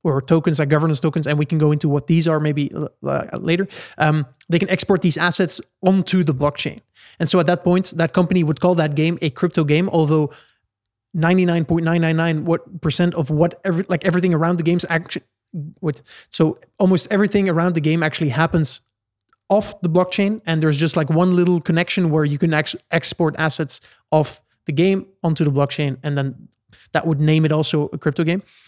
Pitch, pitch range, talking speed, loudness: 165 Hz, 155-175 Hz, 205 wpm, -19 LUFS